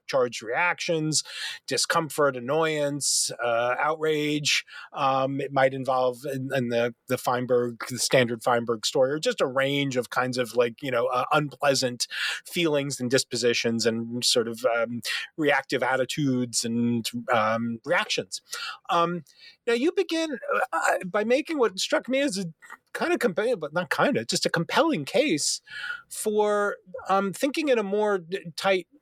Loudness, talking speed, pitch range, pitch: -25 LUFS, 150 wpm, 125-195 Hz, 145 Hz